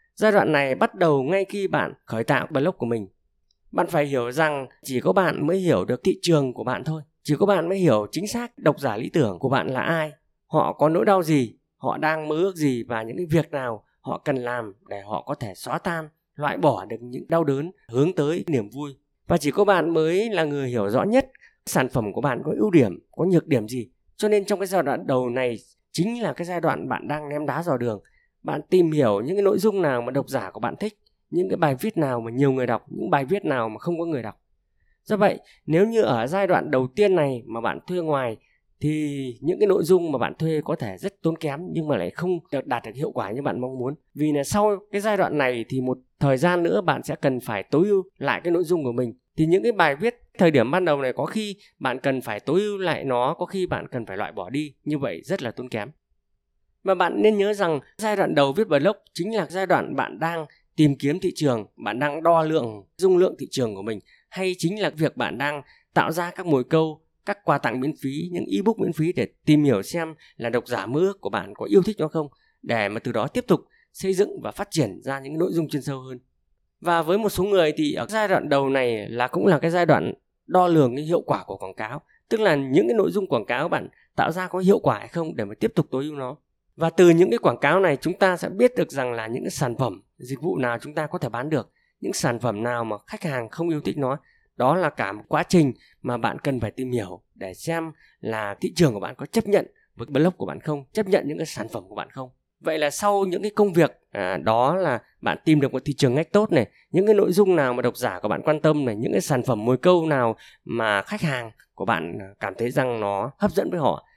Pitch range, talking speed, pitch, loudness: 130-180 Hz, 265 wpm, 155 Hz, -23 LUFS